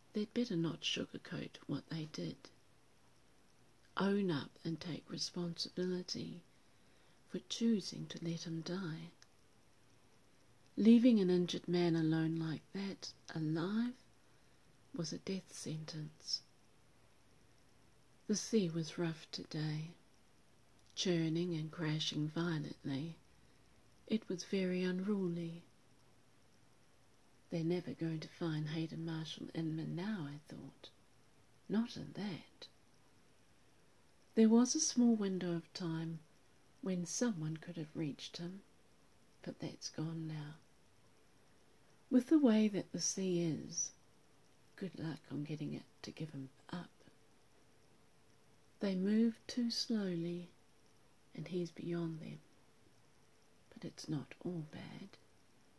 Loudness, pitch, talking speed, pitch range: -39 LUFS, 165 Hz, 110 wpm, 150-185 Hz